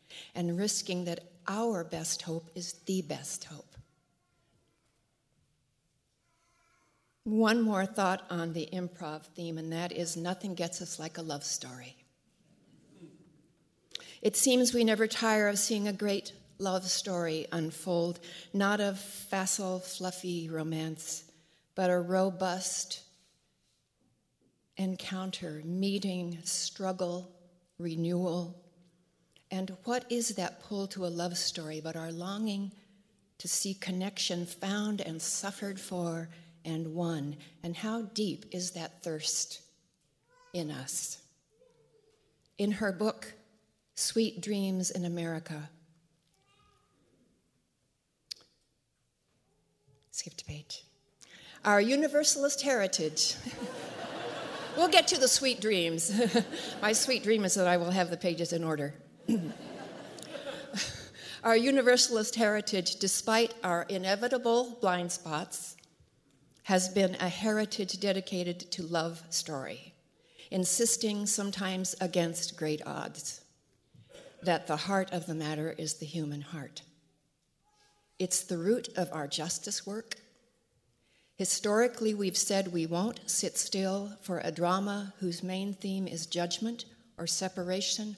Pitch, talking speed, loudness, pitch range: 185 Hz, 115 wpm, -32 LUFS, 170-205 Hz